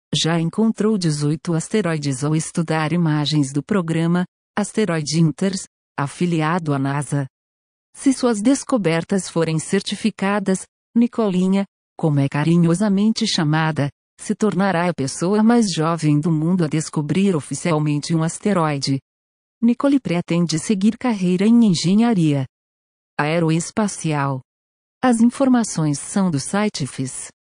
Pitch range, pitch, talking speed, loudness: 150-205 Hz, 170 Hz, 110 wpm, -19 LUFS